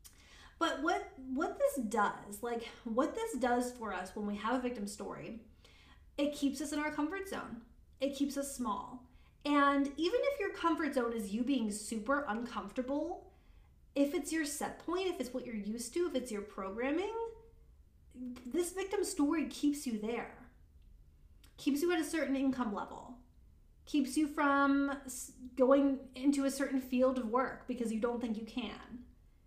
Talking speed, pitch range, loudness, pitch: 170 wpm, 235-295 Hz, -36 LUFS, 265 Hz